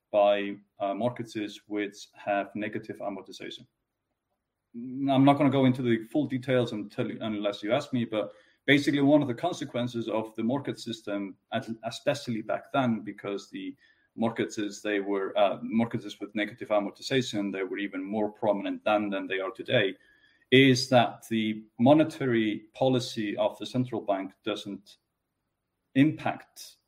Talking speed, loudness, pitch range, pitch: 145 wpm, -28 LUFS, 105-130 Hz, 110 Hz